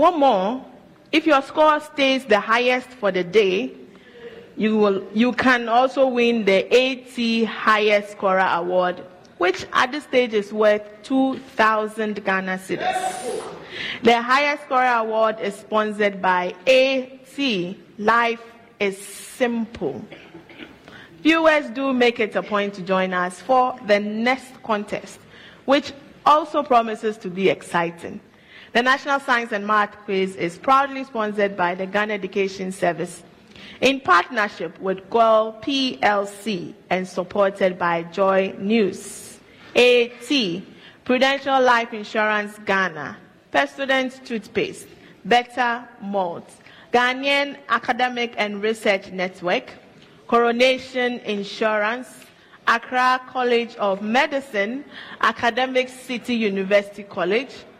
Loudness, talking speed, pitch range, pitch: -20 LUFS, 115 wpm, 200-255 Hz, 220 Hz